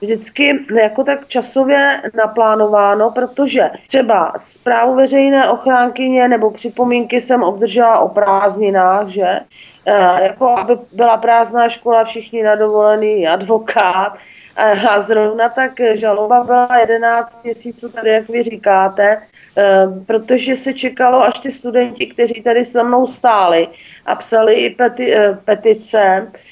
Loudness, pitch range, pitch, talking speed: -13 LUFS, 210-245 Hz, 230 Hz, 125 wpm